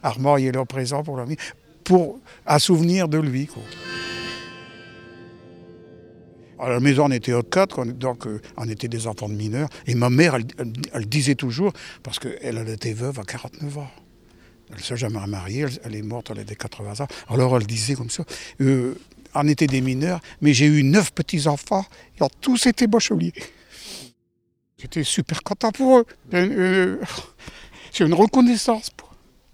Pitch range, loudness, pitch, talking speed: 110-155 Hz, -21 LUFS, 130 Hz, 175 wpm